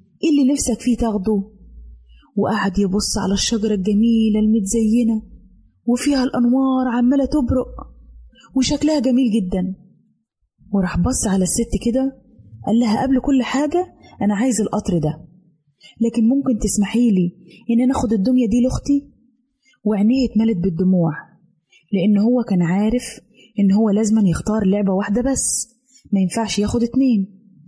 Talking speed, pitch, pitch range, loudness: 130 wpm, 220 Hz, 195-250 Hz, -18 LUFS